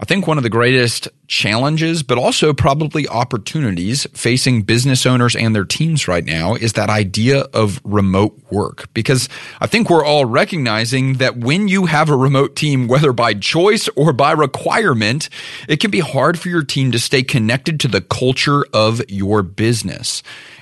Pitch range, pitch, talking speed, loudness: 115-155 Hz, 130 Hz, 175 wpm, -15 LUFS